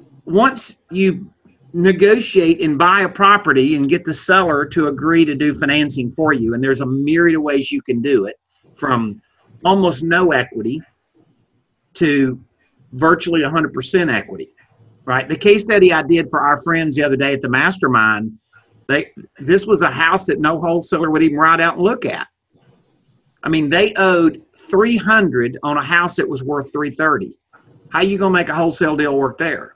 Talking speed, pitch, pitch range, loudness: 180 wpm, 160 Hz, 135-180 Hz, -15 LUFS